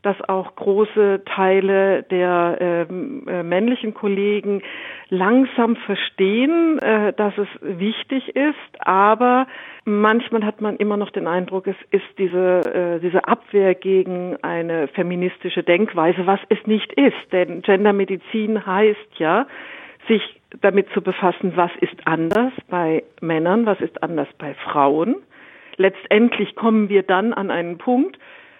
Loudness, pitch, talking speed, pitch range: -19 LUFS, 200 Hz, 130 wpm, 180-220 Hz